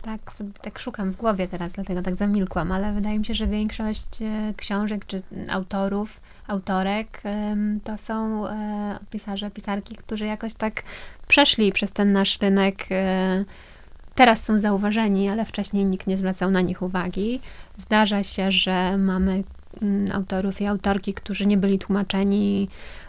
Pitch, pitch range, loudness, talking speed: 200 Hz, 195-215 Hz, -24 LUFS, 140 wpm